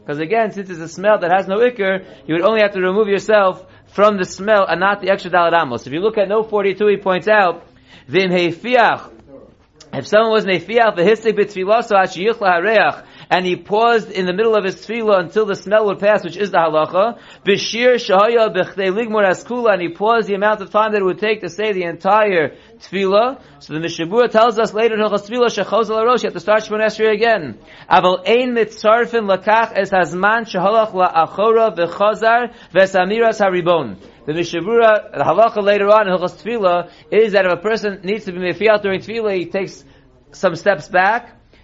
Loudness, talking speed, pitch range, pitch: -16 LUFS, 195 wpm, 180-220 Hz, 200 Hz